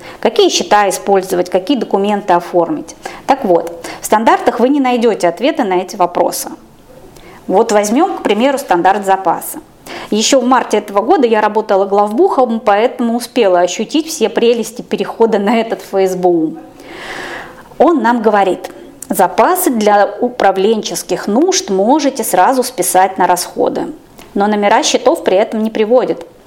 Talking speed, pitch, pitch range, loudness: 135 wpm, 215 Hz, 190-250 Hz, -12 LUFS